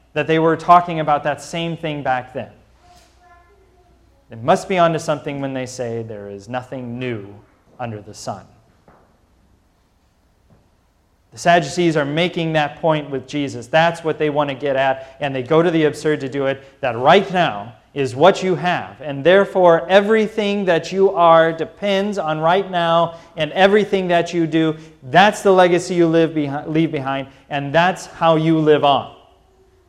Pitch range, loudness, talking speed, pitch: 135-170 Hz, -17 LUFS, 175 wpm, 155 Hz